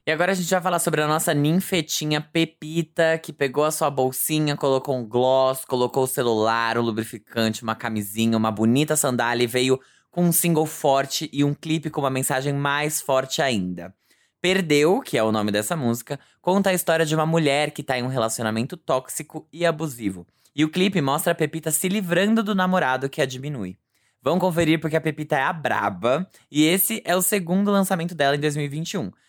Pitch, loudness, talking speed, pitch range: 150 Hz, -22 LUFS, 195 wpm, 130-165 Hz